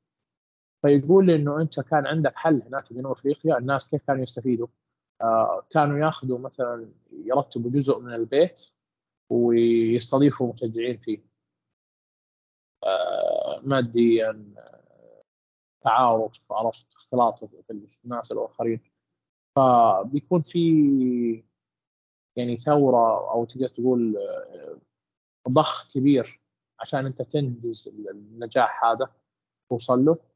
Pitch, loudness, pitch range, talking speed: 130 Hz, -23 LUFS, 115-145 Hz, 95 wpm